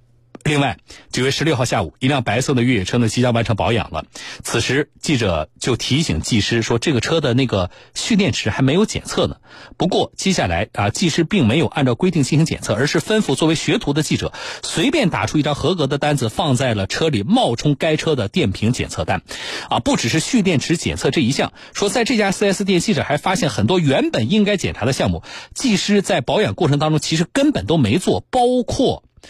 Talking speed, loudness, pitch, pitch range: 325 characters per minute, -18 LUFS, 145 Hz, 120-175 Hz